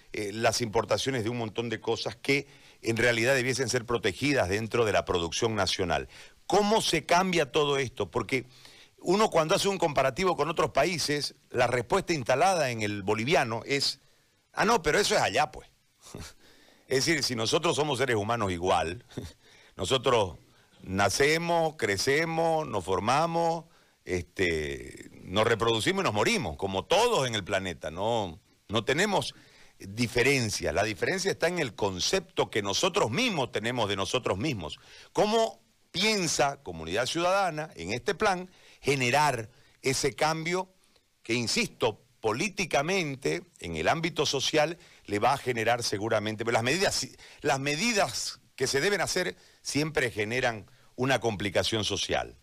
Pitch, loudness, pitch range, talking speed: 135 Hz, -28 LUFS, 115-165 Hz, 140 wpm